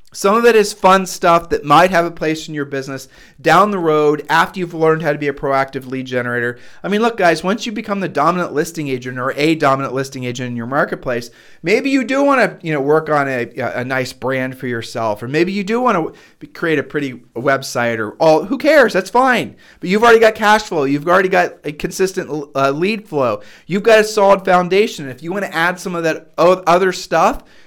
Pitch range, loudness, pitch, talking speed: 135-190 Hz, -15 LUFS, 160 Hz, 230 wpm